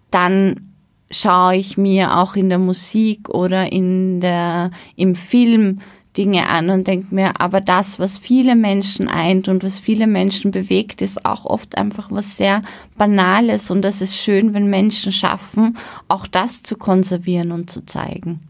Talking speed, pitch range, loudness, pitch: 160 wpm, 185-205 Hz, -16 LUFS, 190 Hz